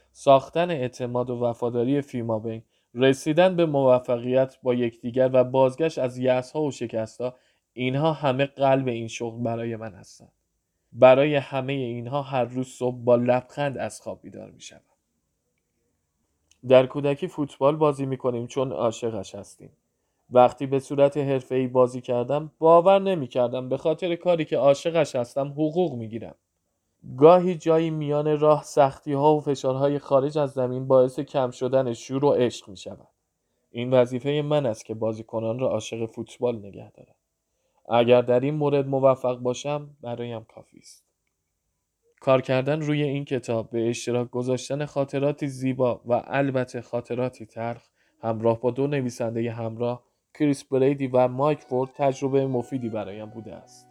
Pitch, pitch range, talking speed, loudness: 130 Hz, 120-140 Hz, 150 wpm, -24 LUFS